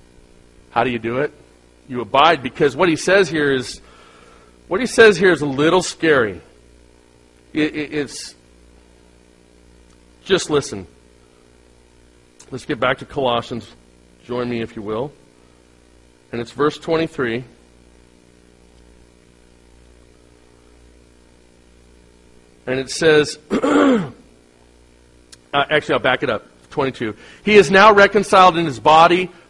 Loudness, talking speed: -16 LUFS, 115 wpm